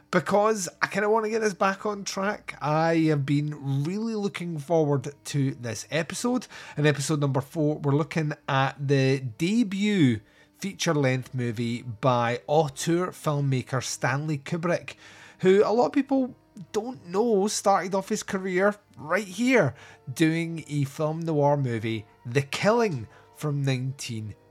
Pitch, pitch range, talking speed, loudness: 155 Hz, 135-195 Hz, 145 wpm, -26 LUFS